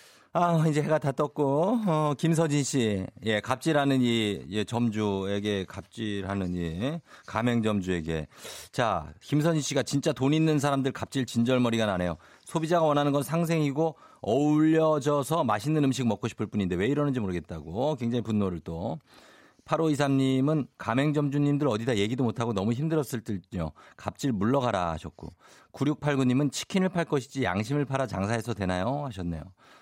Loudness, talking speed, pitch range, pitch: -28 LUFS, 330 characters per minute, 105-150 Hz, 130 Hz